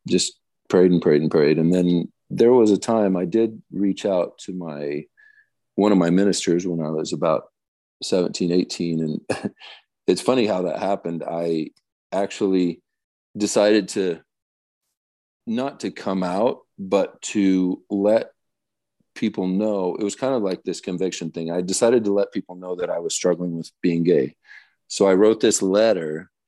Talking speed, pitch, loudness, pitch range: 165 wpm, 90 Hz, -21 LUFS, 85-105 Hz